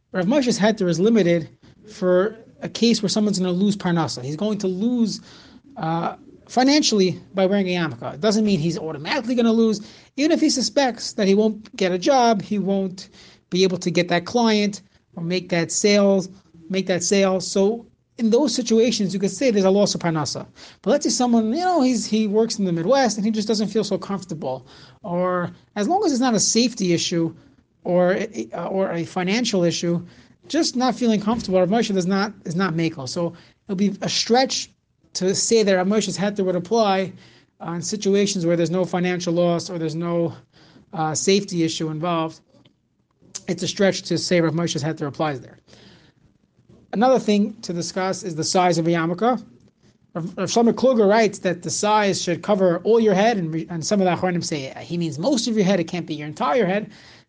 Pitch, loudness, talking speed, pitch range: 190 Hz, -21 LUFS, 200 wpm, 170-220 Hz